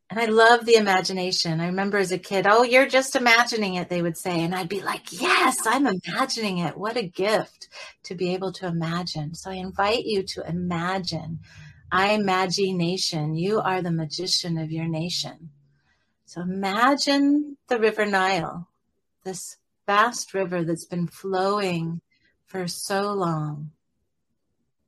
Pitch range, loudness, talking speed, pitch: 170-205 Hz, -23 LUFS, 150 wpm, 185 Hz